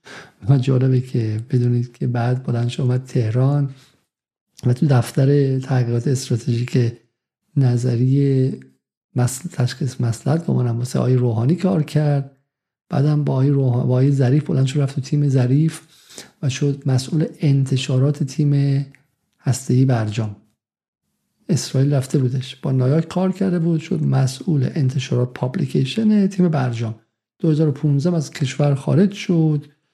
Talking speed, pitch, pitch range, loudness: 130 wpm, 135 Hz, 125-150 Hz, -19 LUFS